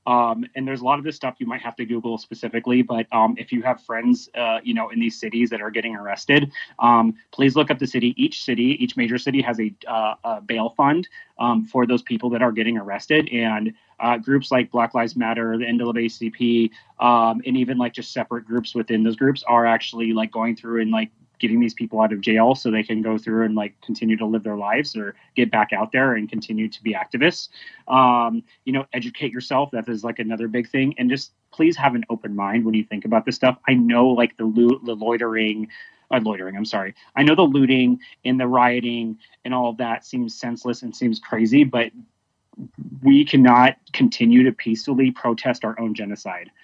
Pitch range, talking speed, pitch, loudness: 115-130 Hz, 220 wpm, 120 Hz, -20 LUFS